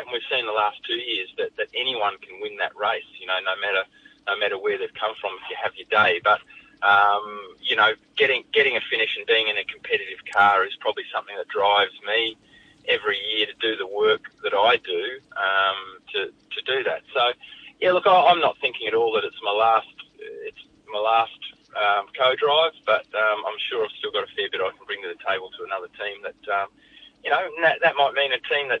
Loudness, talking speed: -22 LUFS, 230 wpm